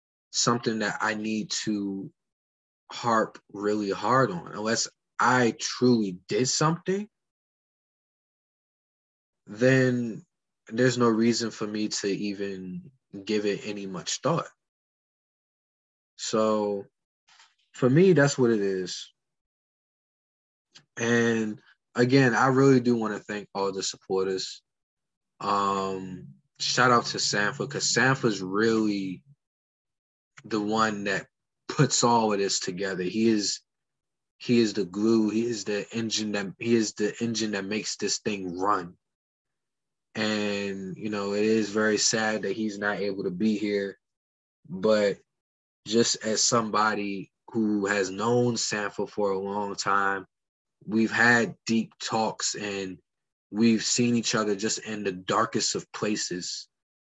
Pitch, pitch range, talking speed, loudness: 105 Hz, 100-115 Hz, 130 wpm, -26 LUFS